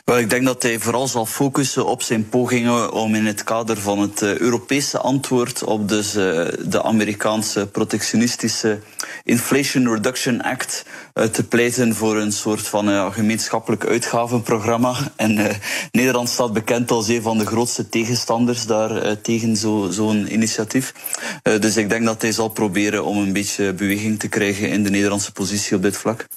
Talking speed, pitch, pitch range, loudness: 155 wpm, 110 Hz, 105-120 Hz, -19 LUFS